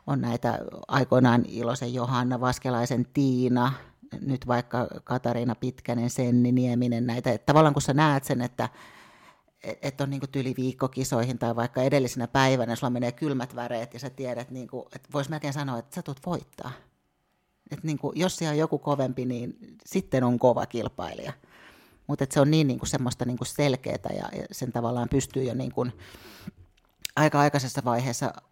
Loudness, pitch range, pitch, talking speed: -27 LUFS, 120-140 Hz, 125 Hz, 165 wpm